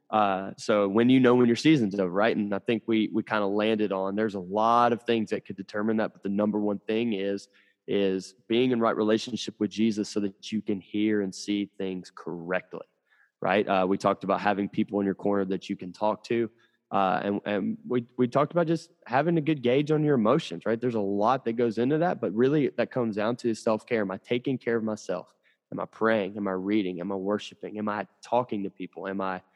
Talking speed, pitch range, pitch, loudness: 240 wpm, 100-115 Hz, 105 Hz, -27 LUFS